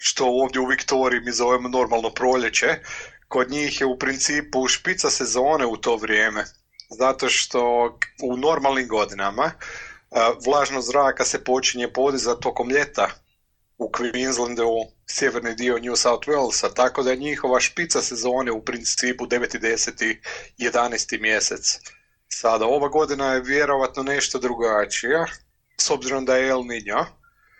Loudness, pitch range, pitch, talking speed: -21 LUFS, 120-135 Hz, 125 Hz, 135 wpm